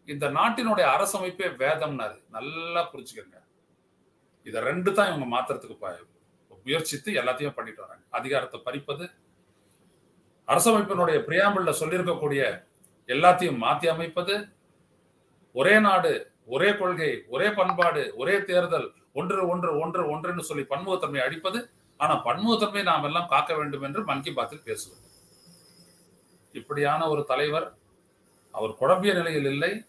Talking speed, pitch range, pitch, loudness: 110 wpm, 145-200 Hz, 175 Hz, -25 LUFS